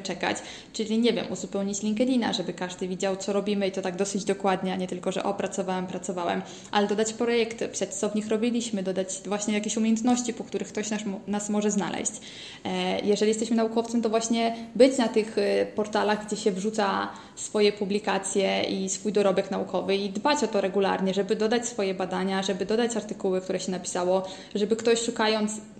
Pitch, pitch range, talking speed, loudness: 205 Hz, 195-220 Hz, 180 wpm, -27 LUFS